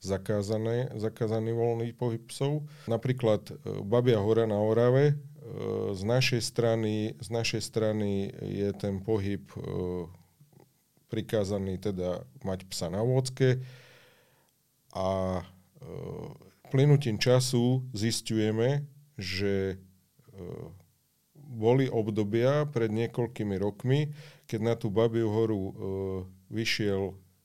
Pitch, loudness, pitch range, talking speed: 115 Hz, -29 LUFS, 100-125 Hz, 105 wpm